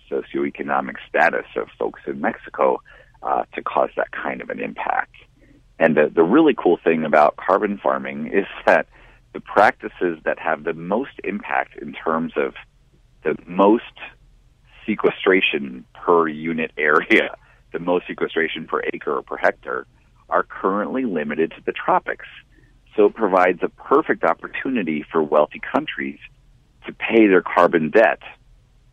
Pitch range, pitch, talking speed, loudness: 75-85 Hz, 80 Hz, 145 wpm, -20 LUFS